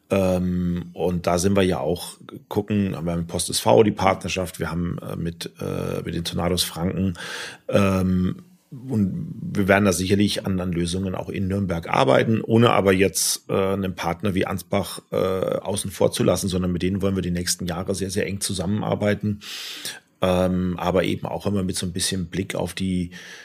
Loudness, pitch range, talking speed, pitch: -23 LUFS, 90-100 Hz, 170 wpm, 95 Hz